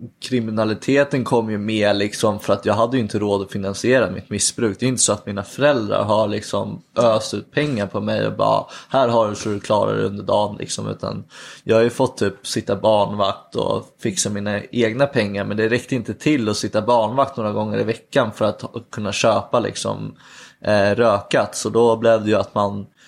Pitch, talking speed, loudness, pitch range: 110 Hz, 210 wpm, -20 LUFS, 100-120 Hz